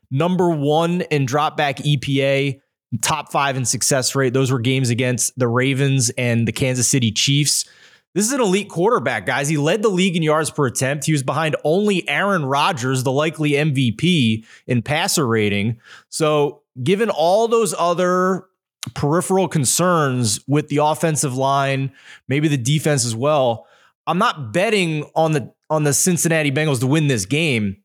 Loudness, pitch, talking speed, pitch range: -18 LUFS, 145 Hz, 165 wpm, 130-165 Hz